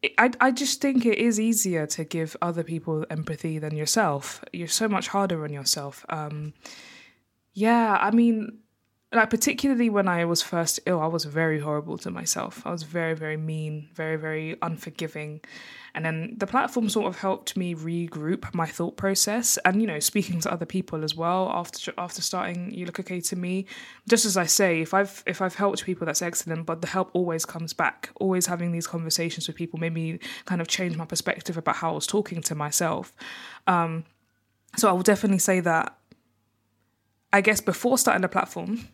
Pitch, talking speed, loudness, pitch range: 175 Hz, 195 wpm, -25 LUFS, 160-200 Hz